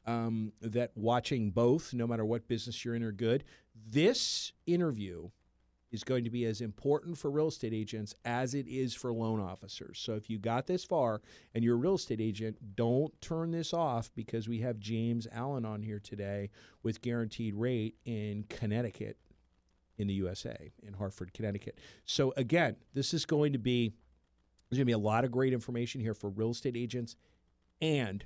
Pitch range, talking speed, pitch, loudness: 110-125 Hz, 185 wpm, 115 Hz, -35 LUFS